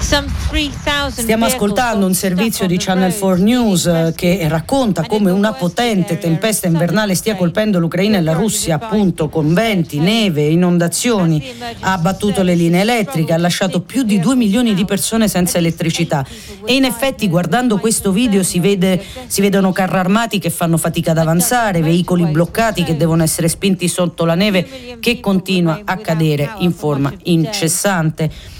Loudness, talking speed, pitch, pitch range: -15 LUFS, 155 wpm, 185 Hz, 165-210 Hz